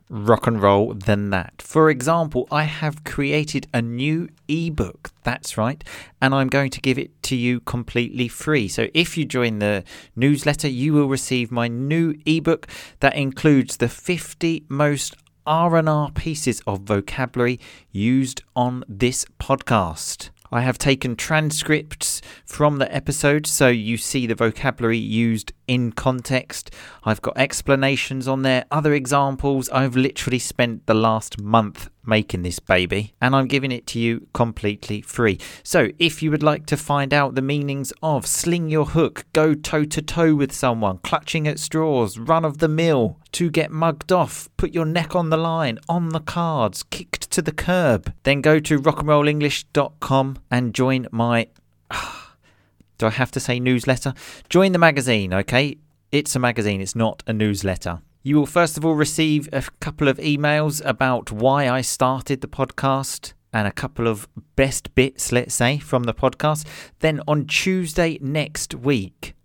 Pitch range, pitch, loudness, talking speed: 115-150 Hz, 135 Hz, -21 LUFS, 165 wpm